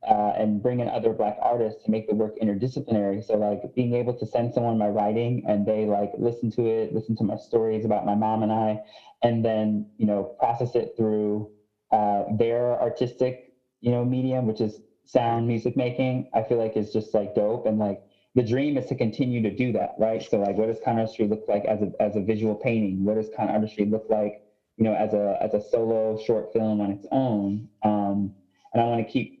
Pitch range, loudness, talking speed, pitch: 105-120 Hz, -25 LUFS, 220 wpm, 110 Hz